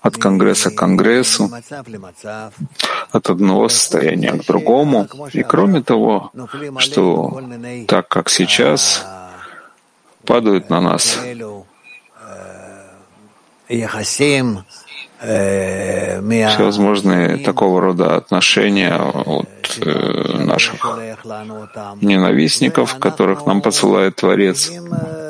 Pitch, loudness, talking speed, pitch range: 105 Hz, -14 LUFS, 70 wpm, 95-120 Hz